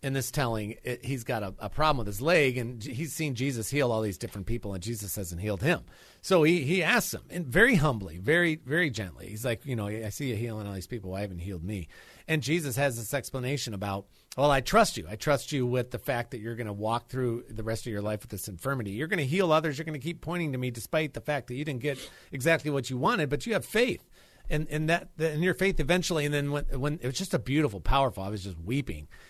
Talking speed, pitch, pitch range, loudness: 270 wpm, 130 Hz, 110-155 Hz, -29 LUFS